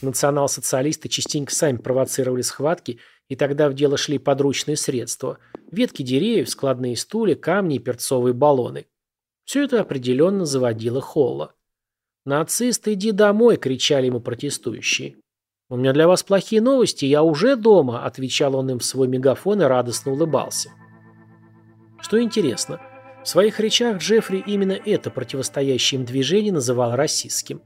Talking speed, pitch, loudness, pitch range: 135 wpm, 140 Hz, -20 LUFS, 125-190 Hz